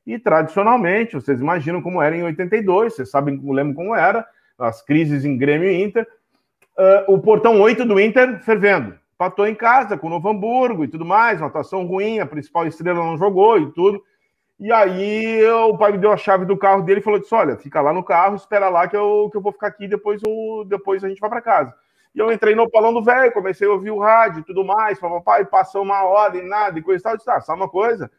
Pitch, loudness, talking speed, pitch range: 200 Hz, -17 LUFS, 230 wpm, 180-220 Hz